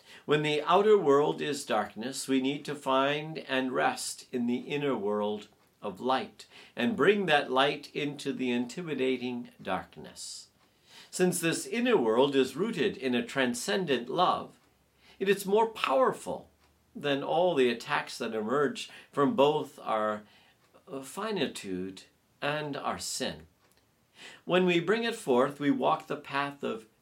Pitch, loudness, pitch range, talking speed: 140 Hz, -29 LUFS, 125-155 Hz, 140 wpm